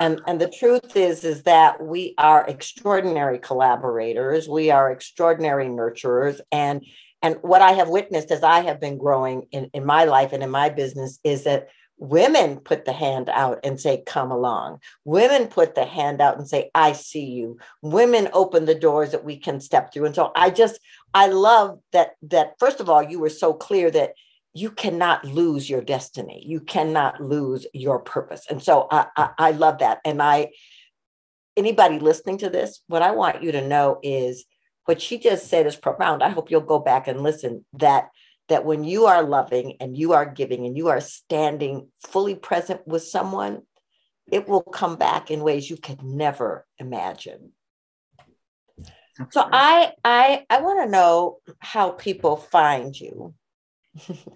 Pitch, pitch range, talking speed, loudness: 155 Hz, 140-185 Hz, 180 wpm, -20 LUFS